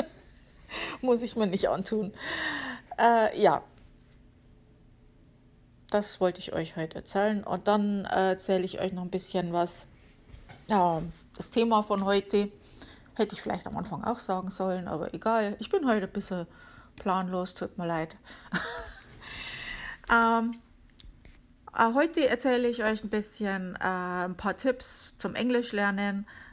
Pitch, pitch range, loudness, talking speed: 200 Hz, 185-225 Hz, -29 LUFS, 140 wpm